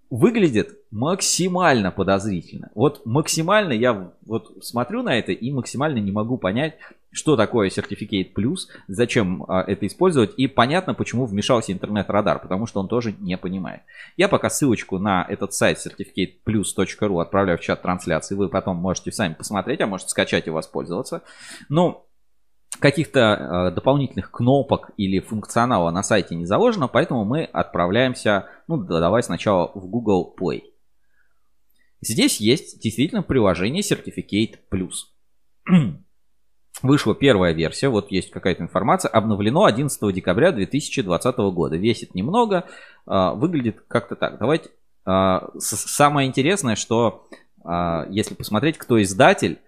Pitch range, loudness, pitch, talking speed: 95-130 Hz, -21 LUFS, 105 Hz, 130 wpm